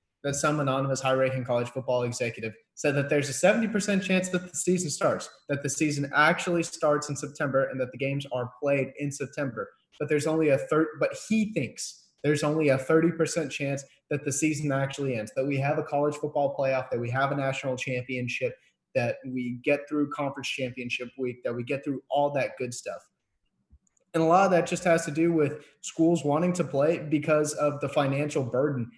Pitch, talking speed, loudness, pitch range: 145 Hz, 200 wpm, -27 LUFS, 135-155 Hz